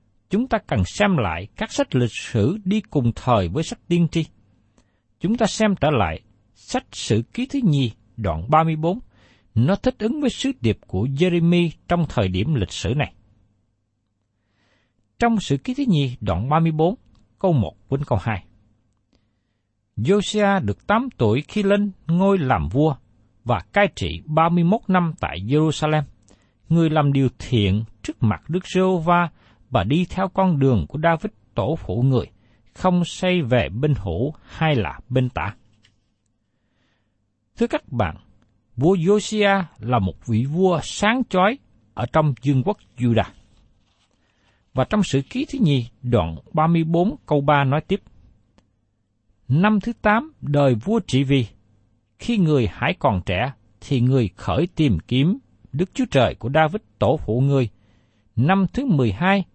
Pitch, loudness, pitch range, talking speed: 130 Hz, -21 LUFS, 105-175 Hz, 155 wpm